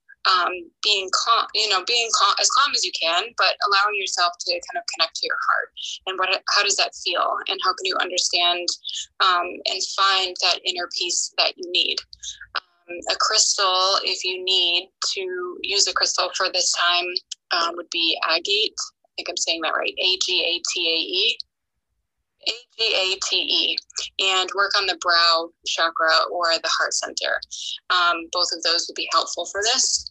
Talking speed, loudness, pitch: 190 wpm, -20 LUFS, 190 Hz